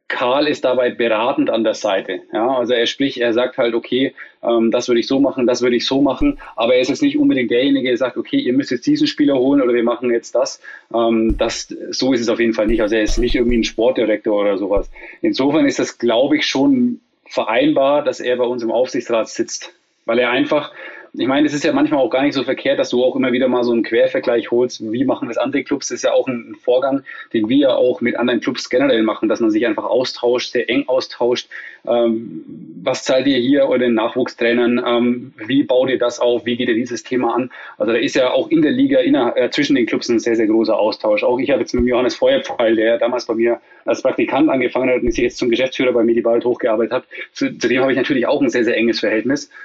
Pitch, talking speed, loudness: 135 Hz, 250 wpm, -17 LUFS